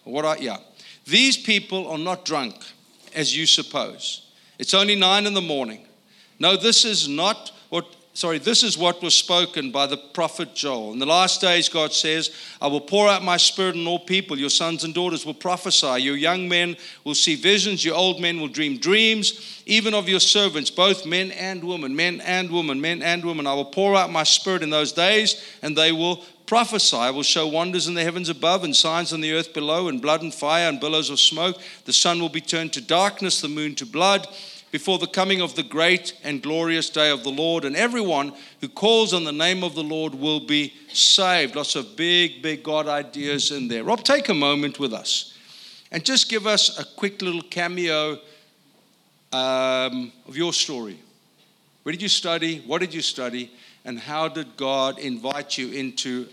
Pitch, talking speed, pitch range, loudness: 170 Hz, 200 wpm, 150-190 Hz, -20 LUFS